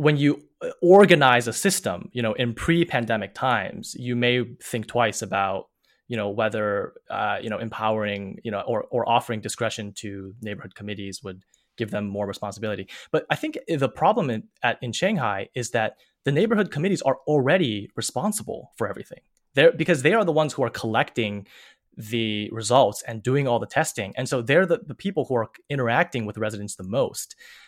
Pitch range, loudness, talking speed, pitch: 105-145 Hz, -24 LUFS, 185 wpm, 120 Hz